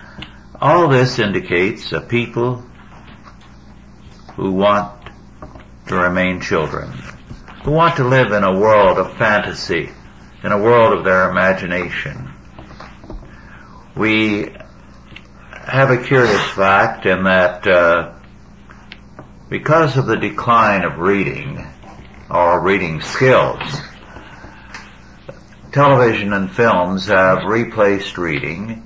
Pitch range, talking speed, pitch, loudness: 95-120 Hz, 100 wpm, 105 Hz, -15 LUFS